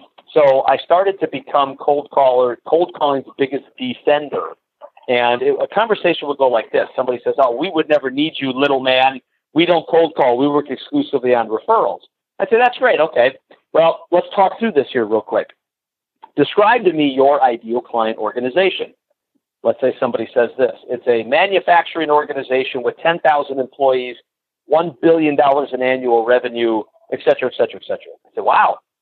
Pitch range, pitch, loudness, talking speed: 130-180 Hz, 150 Hz, -16 LUFS, 175 wpm